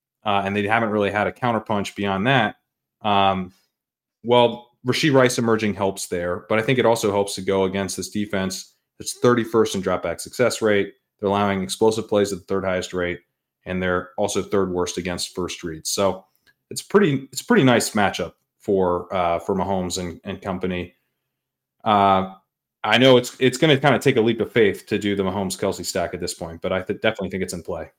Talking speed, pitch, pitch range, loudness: 205 wpm, 100 Hz, 95-110 Hz, -21 LUFS